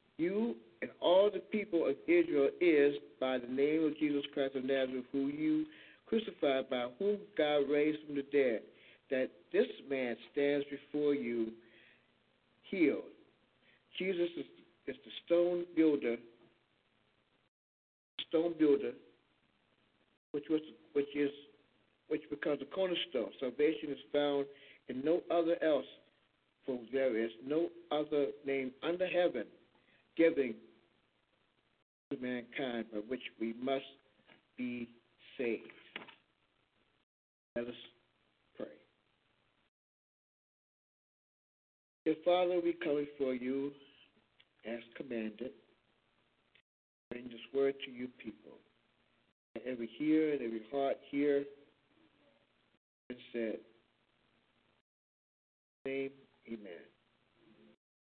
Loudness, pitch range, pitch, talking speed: -36 LUFS, 120-155 Hz, 140 Hz, 105 wpm